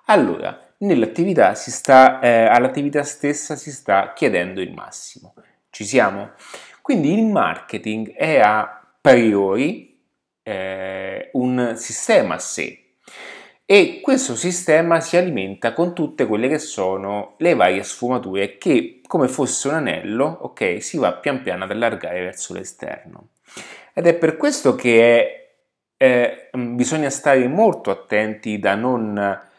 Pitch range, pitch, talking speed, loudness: 105-155 Hz, 120 Hz, 130 wpm, -18 LUFS